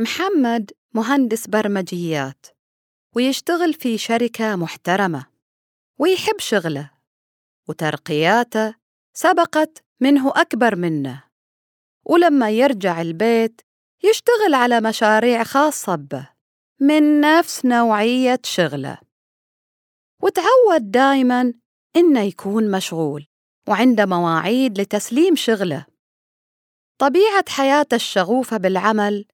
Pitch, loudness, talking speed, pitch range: 230 Hz, -18 LUFS, 80 wpm, 185-280 Hz